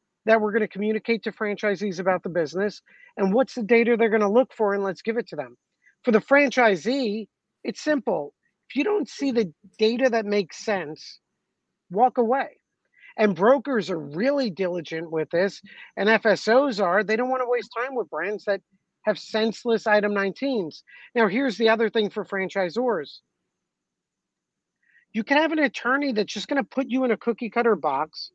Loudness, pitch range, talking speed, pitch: -24 LUFS, 200-250 Hz, 185 wpm, 220 Hz